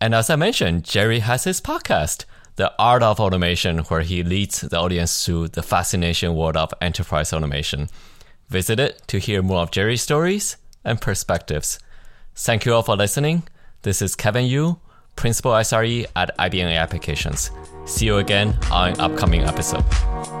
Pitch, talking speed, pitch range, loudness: 95 Hz, 160 wpm, 85-115 Hz, -20 LUFS